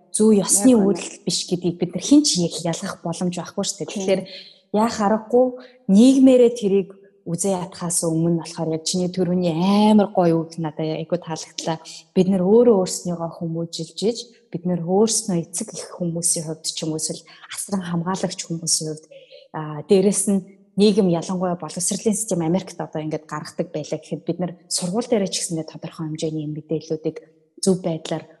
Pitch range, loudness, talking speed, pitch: 165-200 Hz, -21 LUFS, 145 wpm, 180 Hz